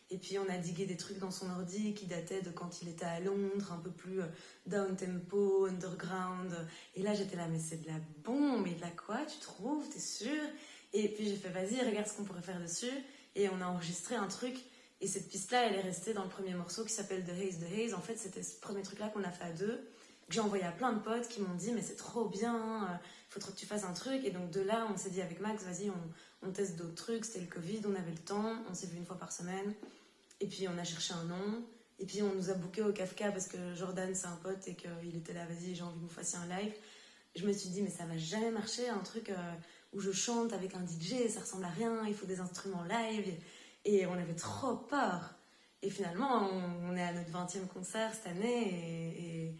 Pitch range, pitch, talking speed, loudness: 180-215 Hz, 195 Hz, 255 wpm, -39 LUFS